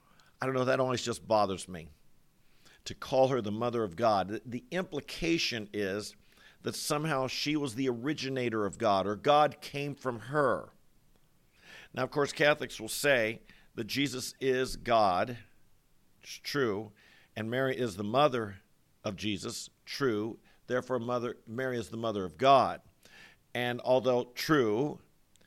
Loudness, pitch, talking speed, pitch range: -31 LUFS, 125 Hz, 145 wpm, 110-135 Hz